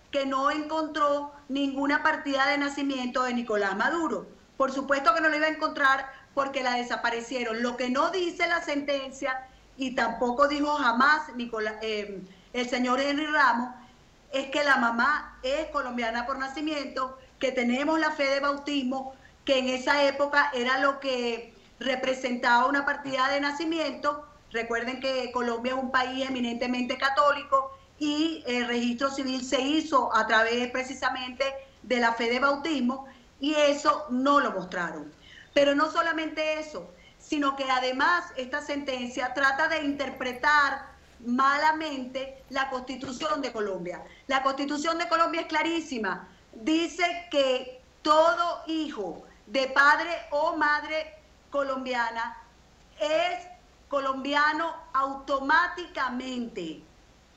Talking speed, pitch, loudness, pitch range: 130 wpm, 270 Hz, -27 LUFS, 255-295 Hz